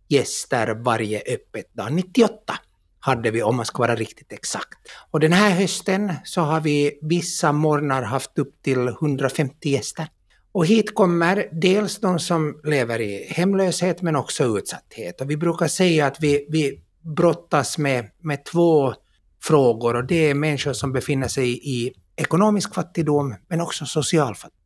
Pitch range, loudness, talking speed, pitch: 135-175 Hz, -21 LUFS, 160 wpm, 155 Hz